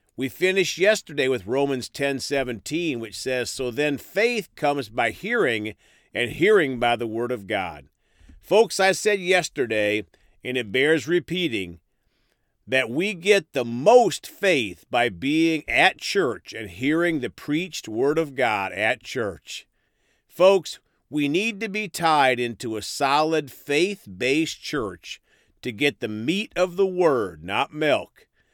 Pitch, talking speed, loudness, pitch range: 145 Hz, 145 wpm, -23 LUFS, 120-175 Hz